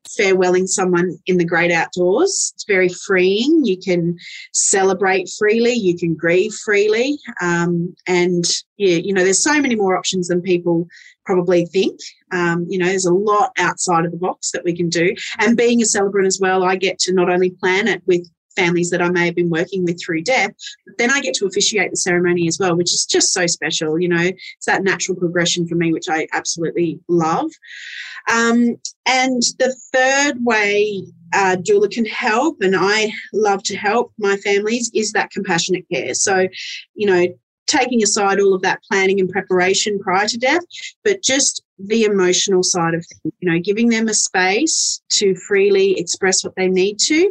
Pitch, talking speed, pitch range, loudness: 190 Hz, 190 wpm, 175-215 Hz, -17 LUFS